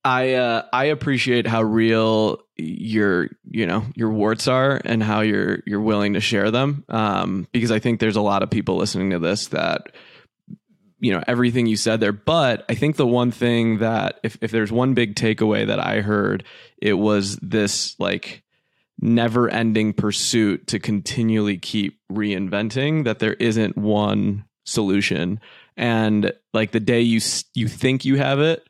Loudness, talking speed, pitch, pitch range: -20 LUFS, 170 wpm, 110 Hz, 105-120 Hz